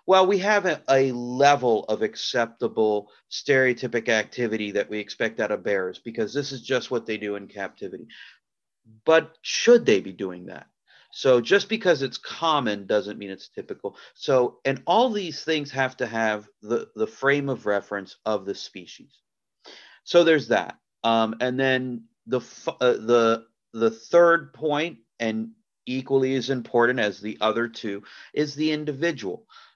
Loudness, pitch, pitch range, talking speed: -24 LUFS, 125 Hz, 110-150 Hz, 160 wpm